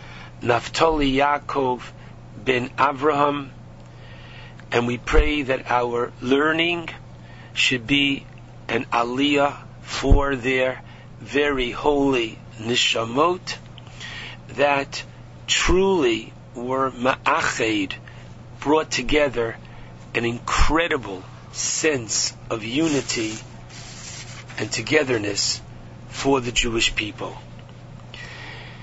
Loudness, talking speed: -22 LUFS, 75 wpm